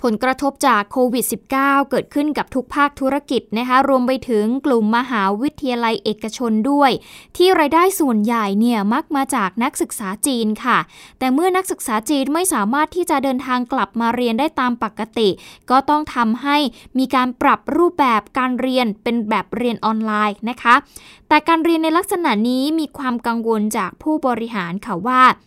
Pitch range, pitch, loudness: 230-285 Hz, 255 Hz, -18 LUFS